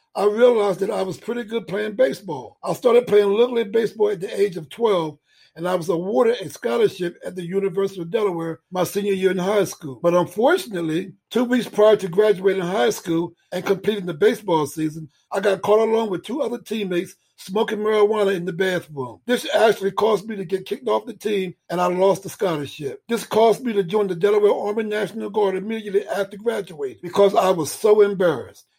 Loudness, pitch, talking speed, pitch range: -21 LUFS, 200 Hz, 200 wpm, 180-220 Hz